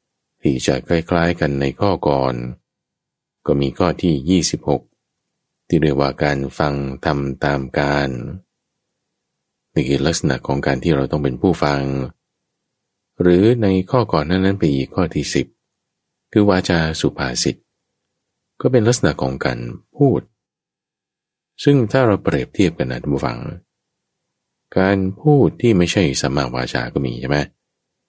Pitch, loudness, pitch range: 75 Hz, -18 LUFS, 70-95 Hz